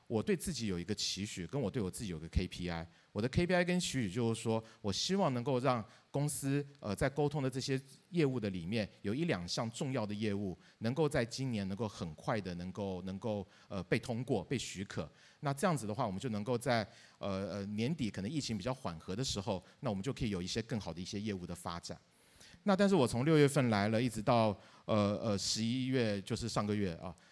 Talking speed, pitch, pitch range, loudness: 330 characters per minute, 110 Hz, 100-130 Hz, -36 LUFS